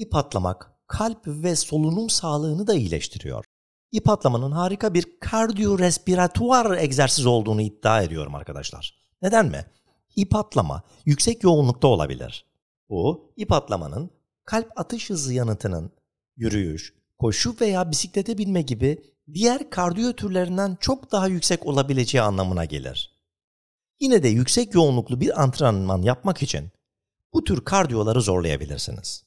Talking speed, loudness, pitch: 125 wpm, -22 LUFS, 145 Hz